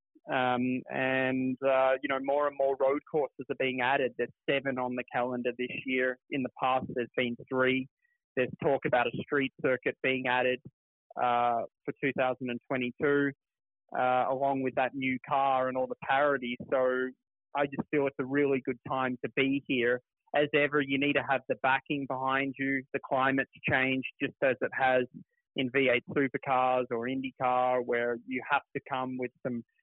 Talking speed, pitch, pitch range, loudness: 175 wpm, 130 Hz, 125-140 Hz, -30 LUFS